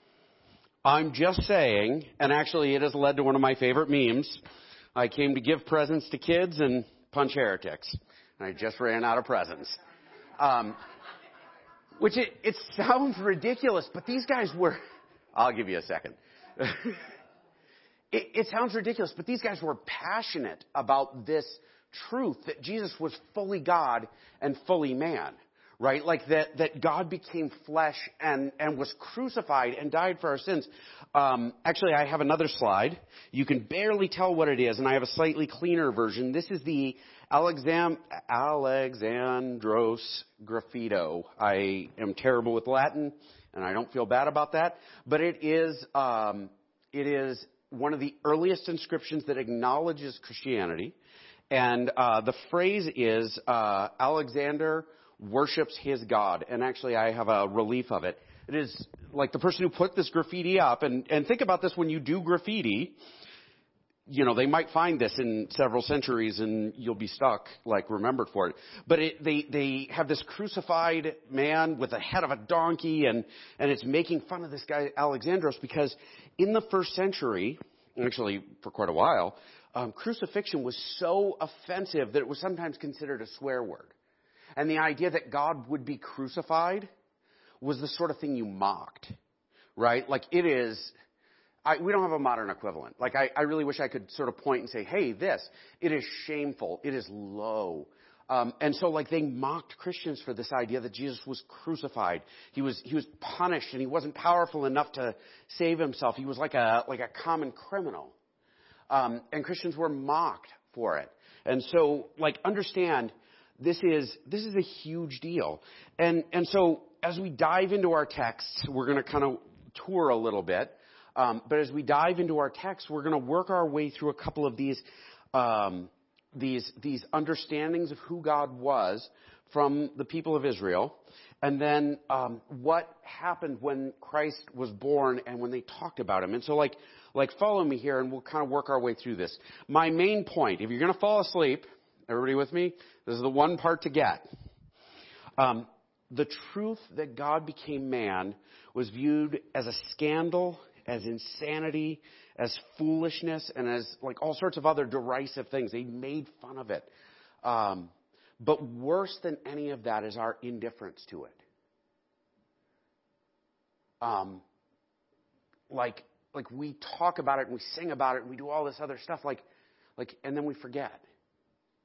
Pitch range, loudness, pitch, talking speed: 130-165 Hz, -30 LUFS, 145 Hz, 175 wpm